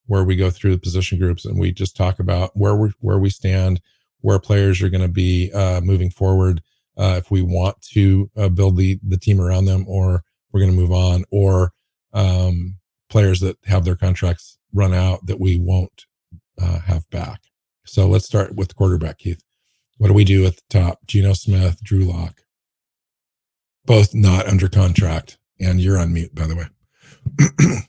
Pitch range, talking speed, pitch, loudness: 90-100 Hz, 190 wpm, 95 Hz, -18 LUFS